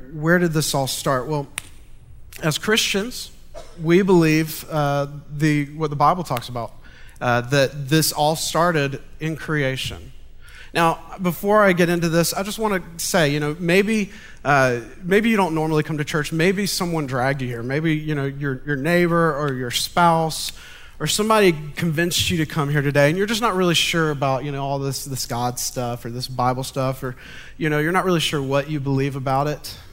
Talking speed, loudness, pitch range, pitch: 195 wpm, -20 LUFS, 135-170 Hz, 150 Hz